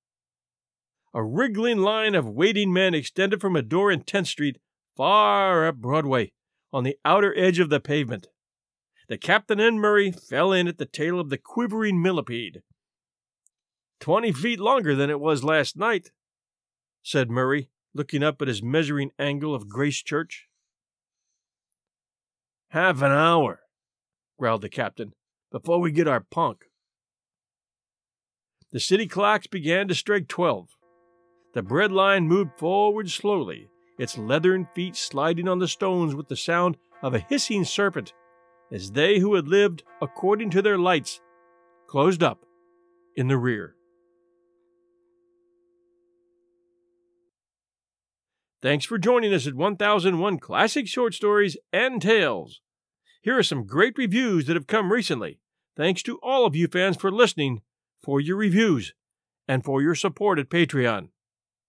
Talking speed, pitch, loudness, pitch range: 140 wpm, 175 Hz, -23 LUFS, 140-205 Hz